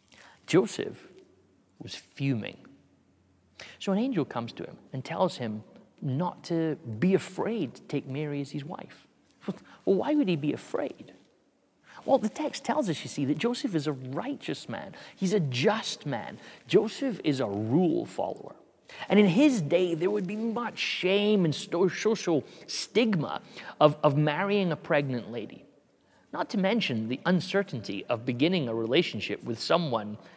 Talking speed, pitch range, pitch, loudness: 155 wpm, 130-200 Hz, 160 Hz, -29 LUFS